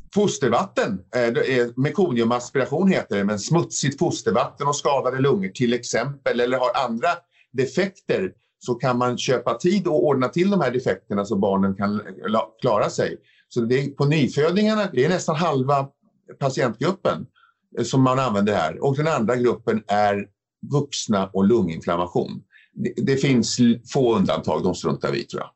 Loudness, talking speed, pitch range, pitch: -22 LUFS, 150 wpm, 120-170 Hz, 130 Hz